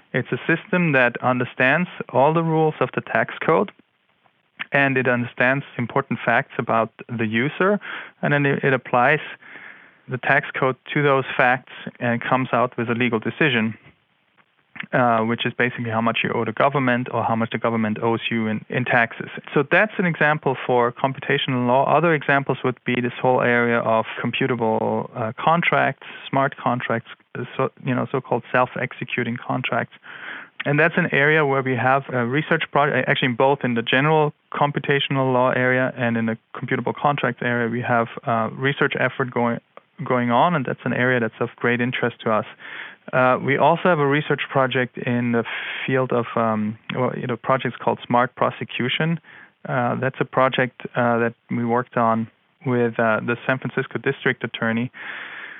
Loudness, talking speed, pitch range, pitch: -21 LUFS, 175 wpm, 120-140 Hz, 125 Hz